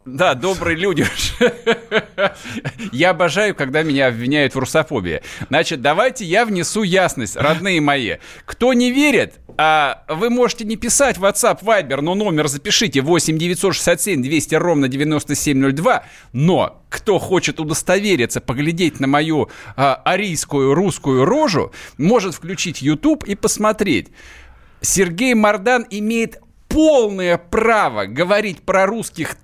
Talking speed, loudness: 120 wpm, -17 LUFS